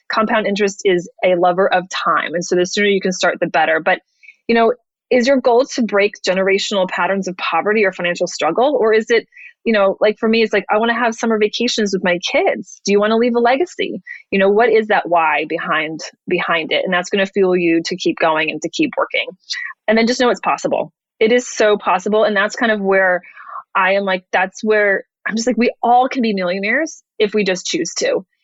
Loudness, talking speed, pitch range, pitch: -16 LUFS, 235 wpm, 185-235 Hz, 210 Hz